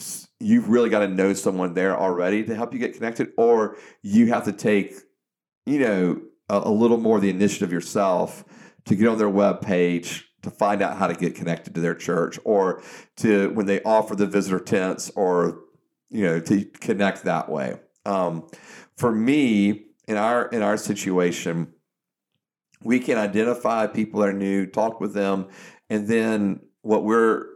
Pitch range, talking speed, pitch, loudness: 95-110 Hz, 175 wpm, 105 Hz, -22 LUFS